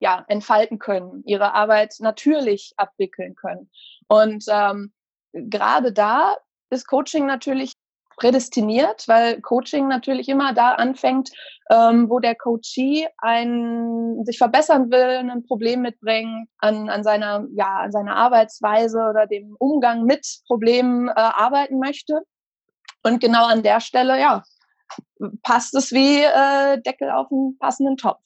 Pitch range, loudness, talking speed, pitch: 220-265 Hz, -19 LUFS, 135 wpm, 240 Hz